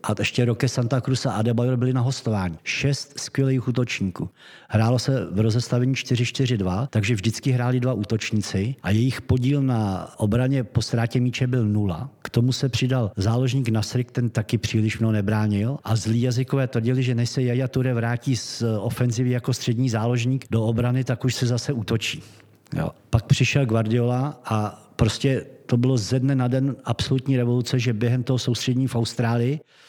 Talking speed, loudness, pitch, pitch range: 175 wpm, -23 LUFS, 125 Hz, 115-130 Hz